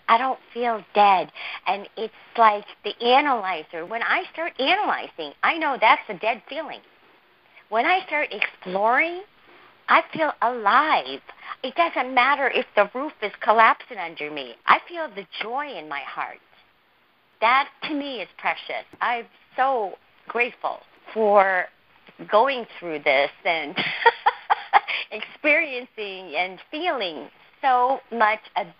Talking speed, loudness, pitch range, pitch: 125 wpm, -22 LUFS, 210-295 Hz, 240 Hz